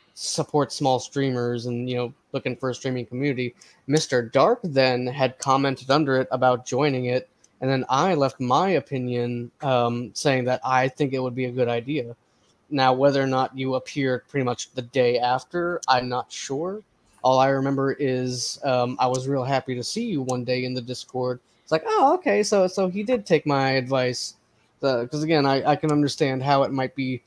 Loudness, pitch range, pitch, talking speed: -23 LUFS, 125-140 Hz, 130 Hz, 200 wpm